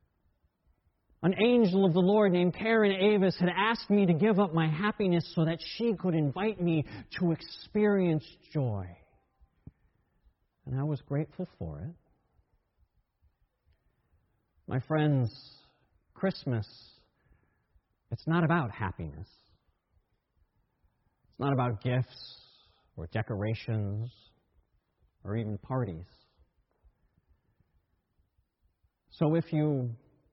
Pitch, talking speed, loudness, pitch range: 130 Hz, 100 wpm, -30 LUFS, 105-175 Hz